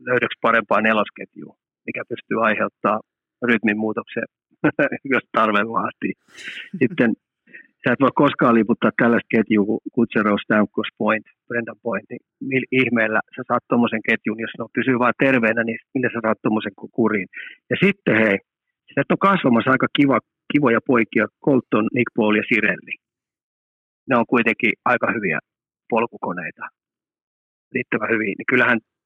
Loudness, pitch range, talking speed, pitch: -20 LUFS, 110-130 Hz, 135 wpm, 115 Hz